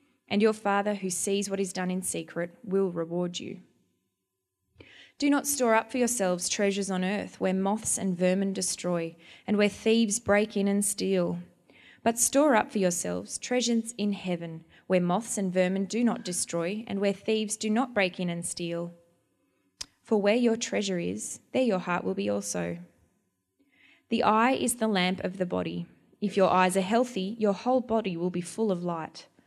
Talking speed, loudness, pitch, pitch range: 185 wpm, -28 LUFS, 195 Hz, 175-220 Hz